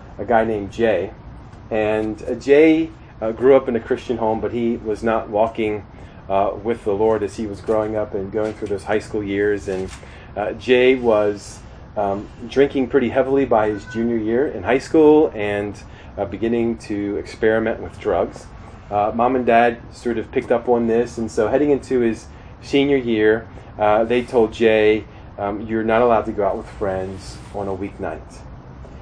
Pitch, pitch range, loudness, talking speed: 110 Hz, 105-120 Hz, -19 LUFS, 185 wpm